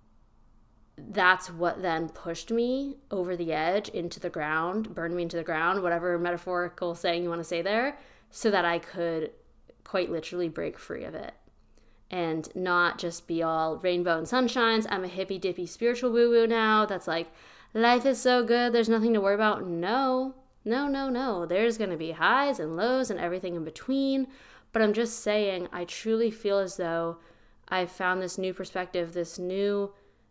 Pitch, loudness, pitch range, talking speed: 185 Hz, -28 LUFS, 170-230 Hz, 180 wpm